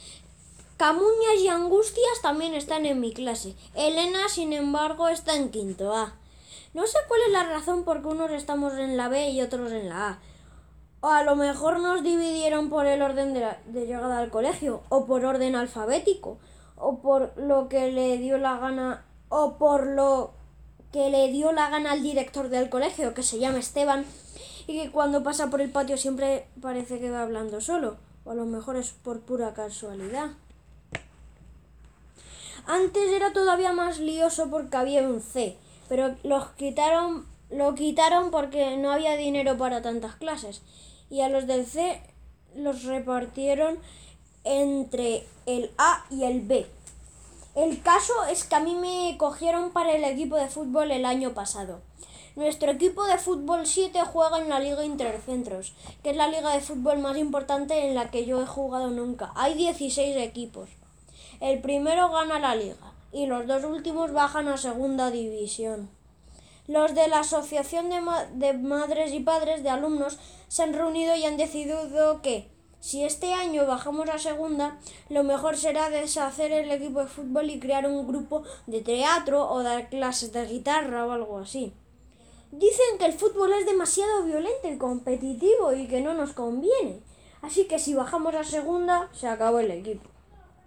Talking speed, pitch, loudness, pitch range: 170 wpm, 285 Hz, -26 LUFS, 255-315 Hz